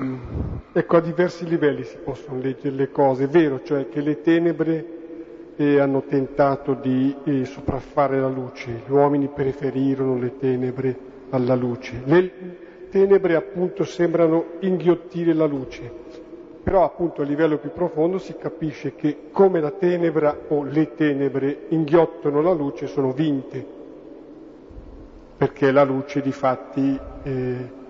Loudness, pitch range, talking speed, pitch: -22 LUFS, 135-165 Hz, 135 wpm, 145 Hz